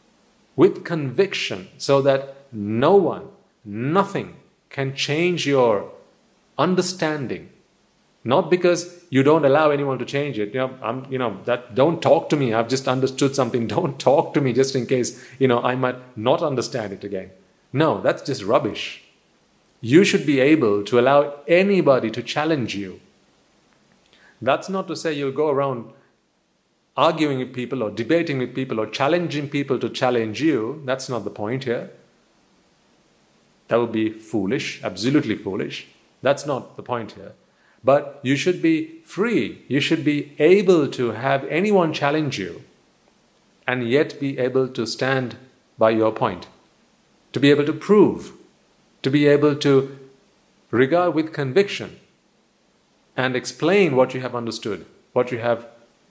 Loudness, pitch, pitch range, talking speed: -21 LUFS, 135 Hz, 125-160 Hz, 155 wpm